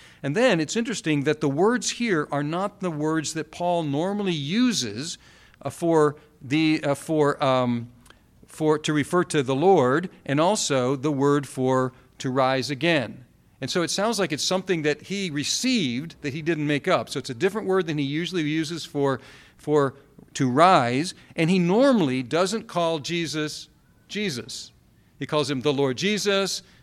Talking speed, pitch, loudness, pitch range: 170 wpm, 155 Hz, -24 LUFS, 140-180 Hz